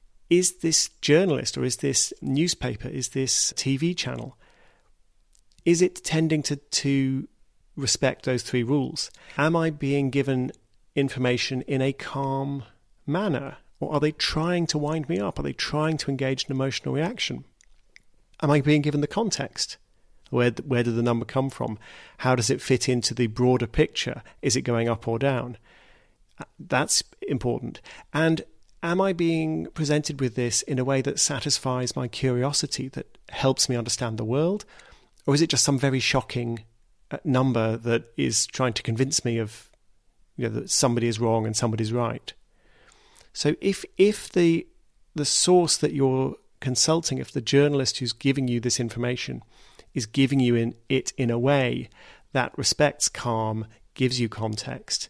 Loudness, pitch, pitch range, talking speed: -25 LUFS, 135 Hz, 120-150 Hz, 165 wpm